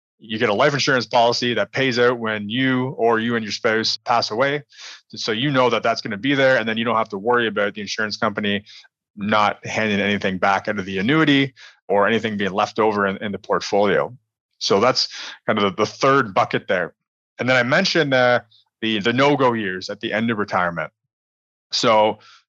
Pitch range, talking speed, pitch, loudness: 105-125 Hz, 210 wpm, 110 Hz, -20 LUFS